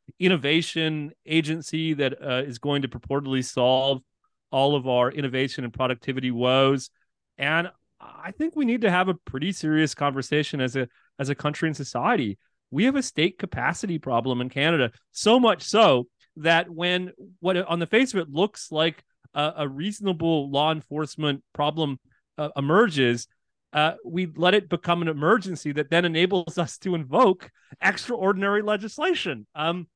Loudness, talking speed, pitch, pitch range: -24 LUFS, 160 wpm, 155 Hz, 135-180 Hz